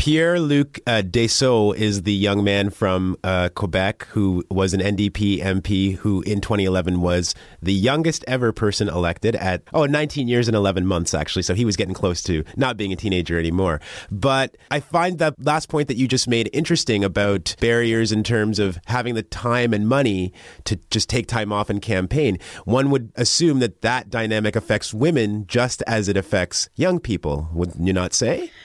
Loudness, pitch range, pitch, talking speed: -21 LUFS, 95-120 Hz, 105 Hz, 190 wpm